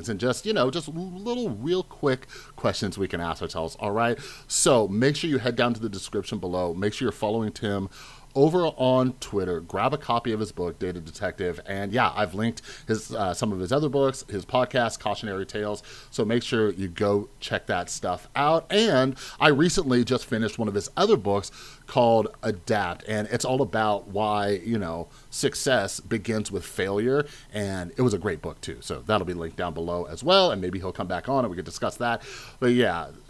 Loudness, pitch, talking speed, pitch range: -26 LUFS, 115 Hz, 210 wpm, 100-130 Hz